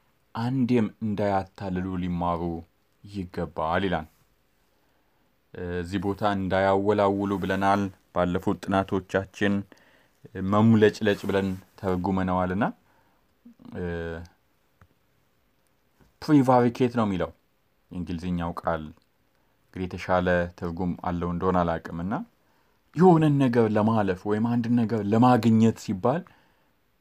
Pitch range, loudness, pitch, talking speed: 90-110 Hz, -25 LUFS, 95 Hz, 75 wpm